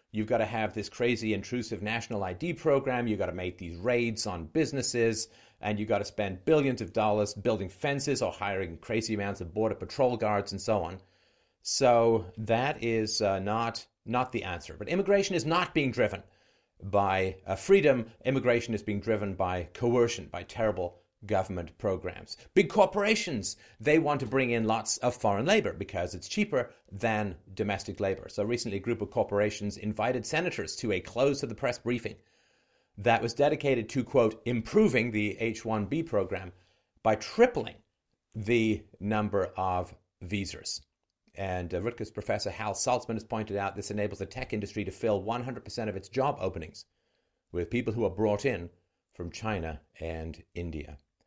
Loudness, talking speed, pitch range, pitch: -30 LUFS, 170 wpm, 95-120 Hz, 110 Hz